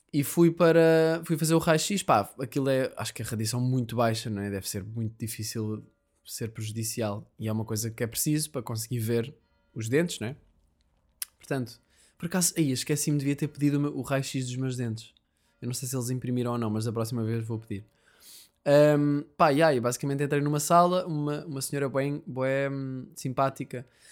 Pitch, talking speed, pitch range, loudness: 130 Hz, 200 wpm, 115-145 Hz, -28 LUFS